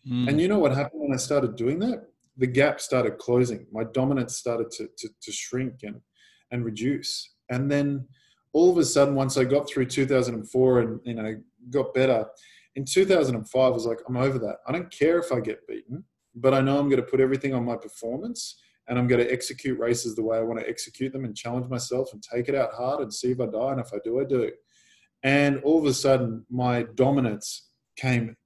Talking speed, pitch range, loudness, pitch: 230 wpm, 120-140 Hz, -25 LUFS, 130 Hz